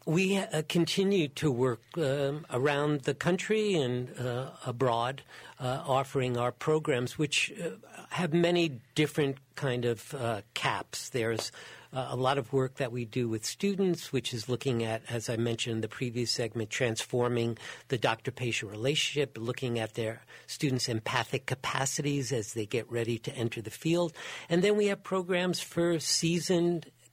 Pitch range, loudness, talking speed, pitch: 120-160 Hz, -31 LUFS, 160 wpm, 135 Hz